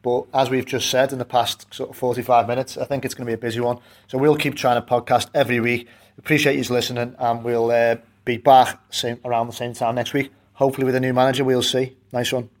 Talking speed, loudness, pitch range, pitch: 250 wpm, -21 LUFS, 120-130 Hz, 125 Hz